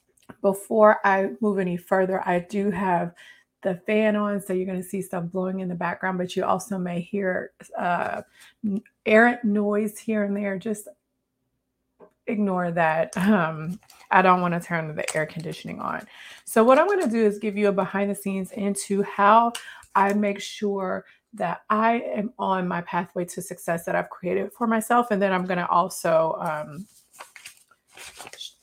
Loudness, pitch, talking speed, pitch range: -24 LUFS, 195 Hz, 170 wpm, 180-210 Hz